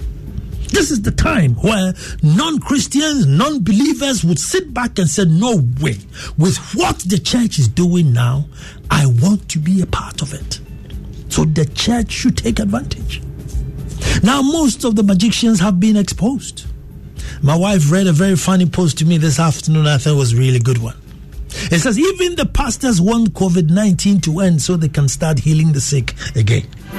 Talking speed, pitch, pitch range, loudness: 180 wpm, 175 Hz, 150-215 Hz, -15 LUFS